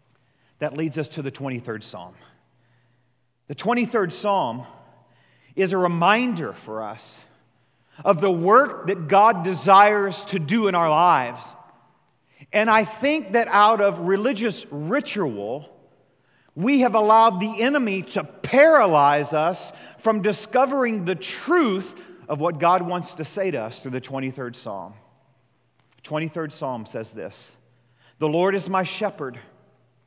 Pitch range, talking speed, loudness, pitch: 130-210 Hz, 135 wpm, -21 LUFS, 175 Hz